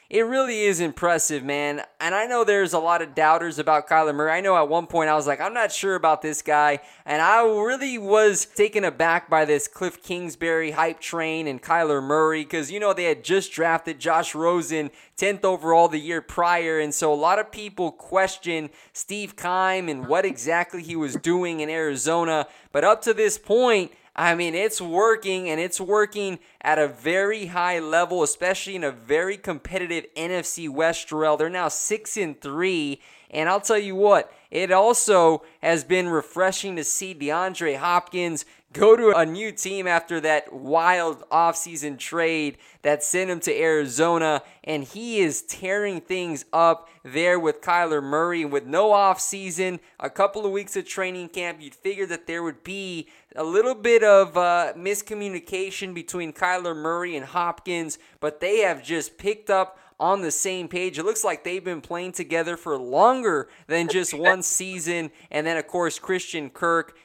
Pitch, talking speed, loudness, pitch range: 170 Hz, 180 wpm, -23 LUFS, 160-190 Hz